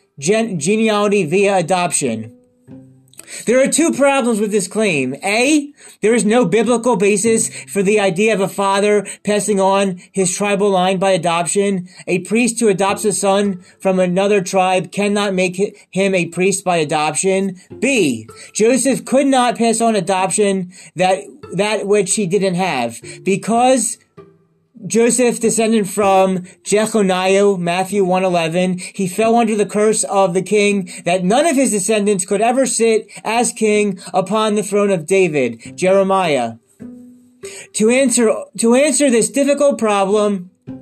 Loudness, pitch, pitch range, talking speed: -15 LUFS, 200 Hz, 185-220 Hz, 145 wpm